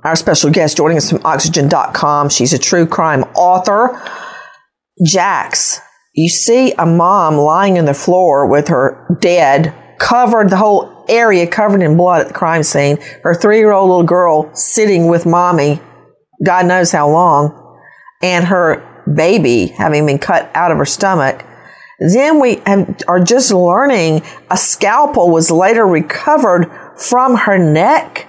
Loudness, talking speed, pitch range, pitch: -11 LUFS, 155 wpm, 155-195 Hz, 175 Hz